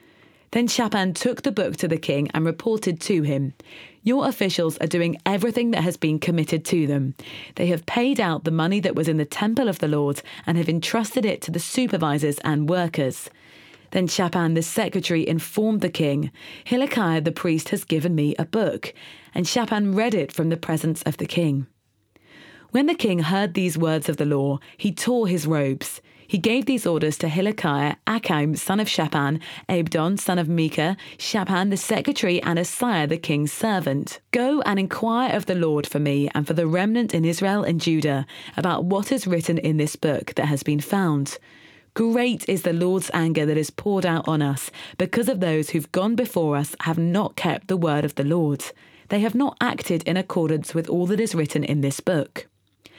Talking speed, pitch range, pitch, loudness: 195 wpm, 155-205 Hz, 170 Hz, -23 LUFS